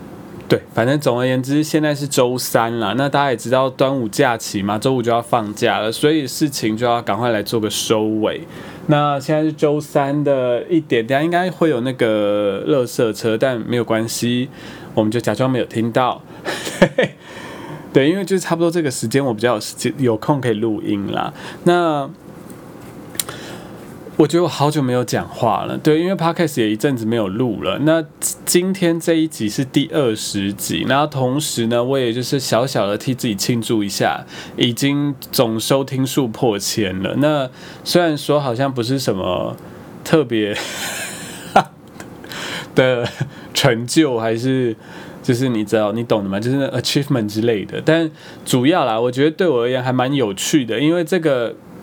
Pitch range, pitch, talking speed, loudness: 115-155 Hz, 130 Hz, 275 characters per minute, -18 LUFS